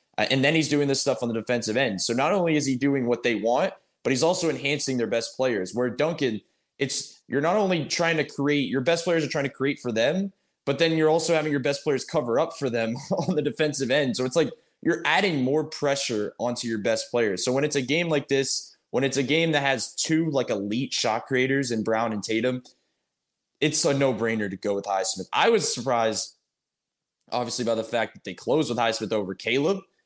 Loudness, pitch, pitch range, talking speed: -25 LUFS, 135 Hz, 115-150 Hz, 230 wpm